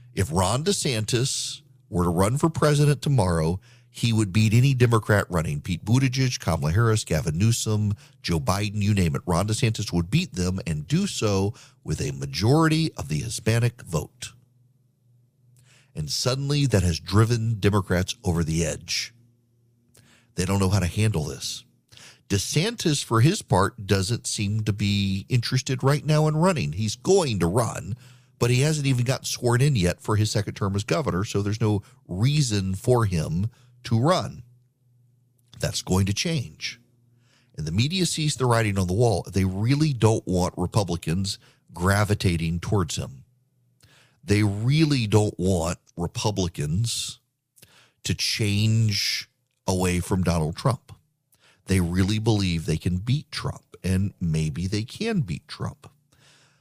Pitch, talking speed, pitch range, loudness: 115 Hz, 150 wpm, 95-130 Hz, -24 LUFS